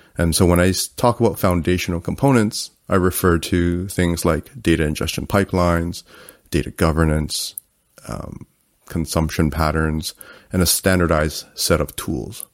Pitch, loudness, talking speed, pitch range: 85 Hz, -19 LUFS, 130 wpm, 80-90 Hz